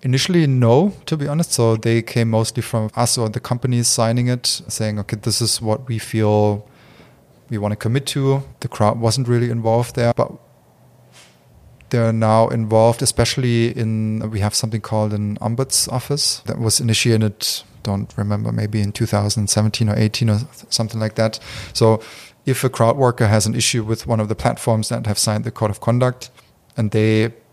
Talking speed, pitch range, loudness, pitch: 180 wpm, 110-120 Hz, -18 LUFS, 115 Hz